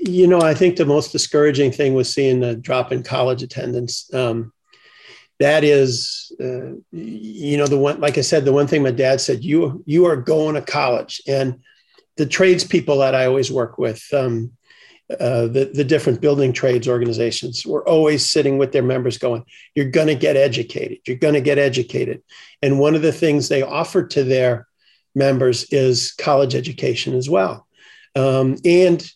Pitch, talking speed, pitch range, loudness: 135 Hz, 185 wpm, 125-150 Hz, -18 LUFS